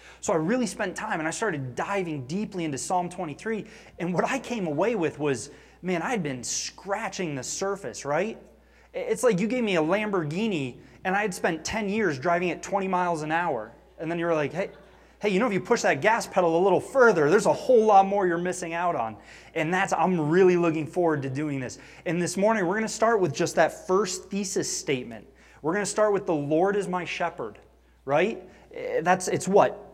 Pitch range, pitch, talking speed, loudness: 160-205 Hz, 180 Hz, 215 wpm, -26 LUFS